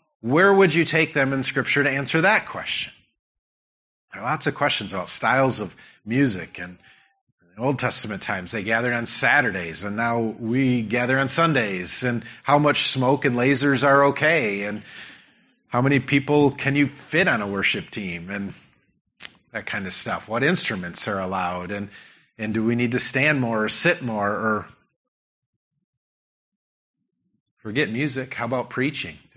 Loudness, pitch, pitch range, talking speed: -22 LUFS, 125 Hz, 105-140 Hz, 165 wpm